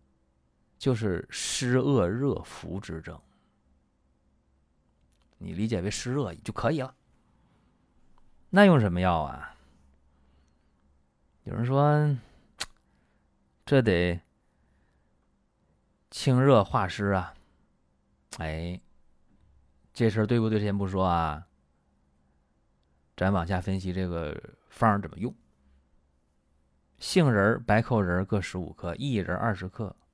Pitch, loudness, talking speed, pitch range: 85 Hz, -27 LUFS, 140 characters per minute, 65-105 Hz